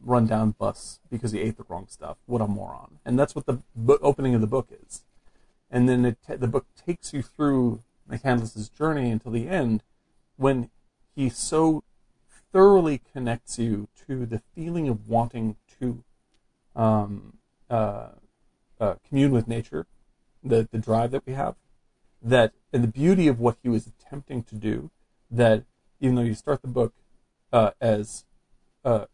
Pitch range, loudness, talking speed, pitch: 115-135 Hz, -25 LUFS, 170 wpm, 120 Hz